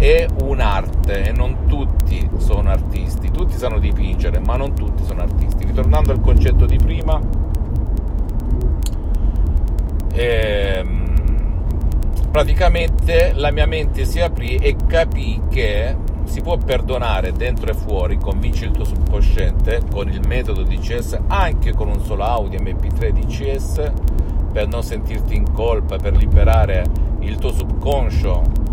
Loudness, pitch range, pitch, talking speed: -19 LUFS, 75-80 Hz, 75 Hz, 130 wpm